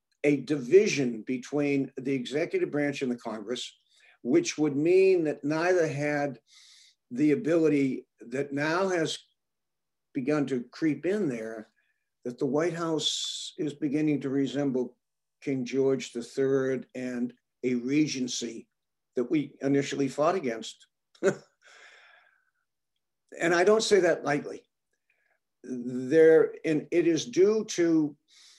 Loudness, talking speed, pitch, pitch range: -27 LUFS, 120 wpm, 145 Hz, 130-165 Hz